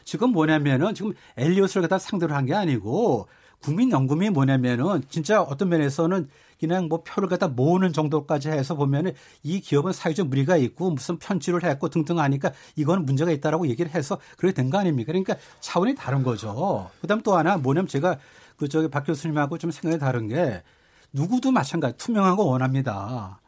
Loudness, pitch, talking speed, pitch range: -24 LUFS, 165 Hz, 405 characters per minute, 140-185 Hz